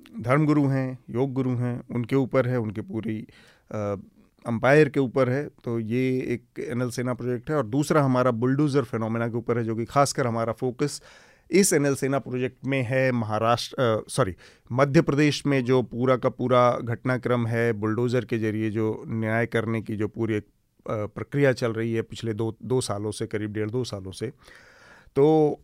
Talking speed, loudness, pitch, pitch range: 180 wpm, -25 LUFS, 125 Hz, 115-135 Hz